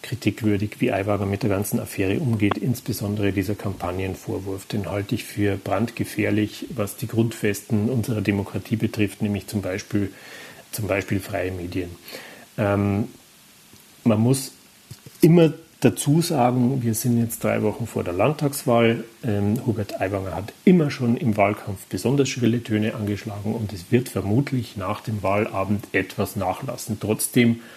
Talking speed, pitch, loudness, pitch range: 140 wpm, 110 Hz, -23 LUFS, 100-120 Hz